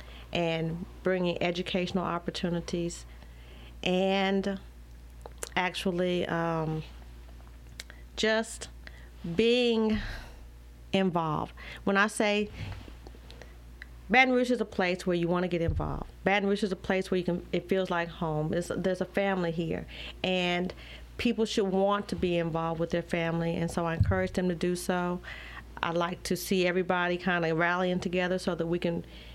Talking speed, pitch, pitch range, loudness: 150 wpm, 175 Hz, 155-190 Hz, -29 LUFS